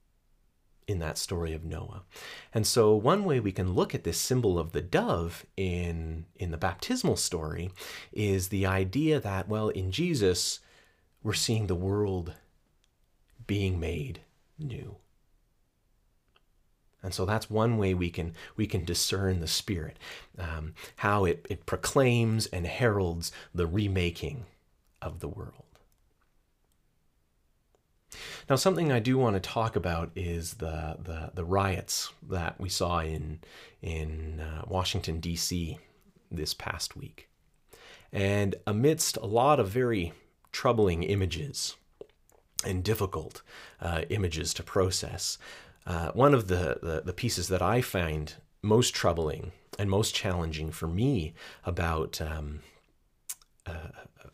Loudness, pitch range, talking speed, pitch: -30 LUFS, 85-105 Hz, 130 wpm, 95 Hz